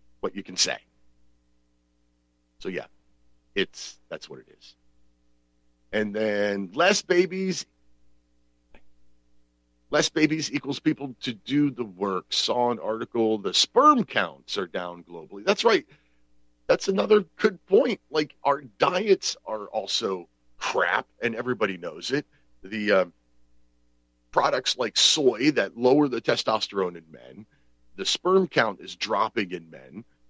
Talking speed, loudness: 130 wpm, -25 LUFS